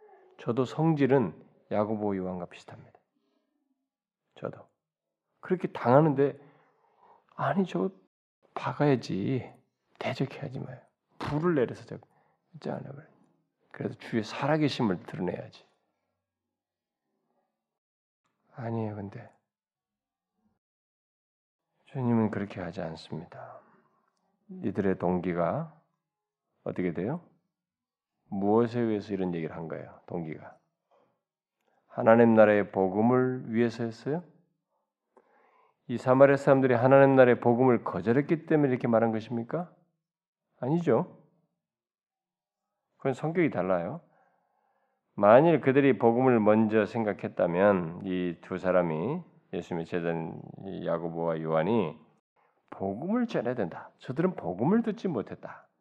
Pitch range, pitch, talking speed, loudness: 105-165 Hz, 125 Hz, 240 characters per minute, -27 LUFS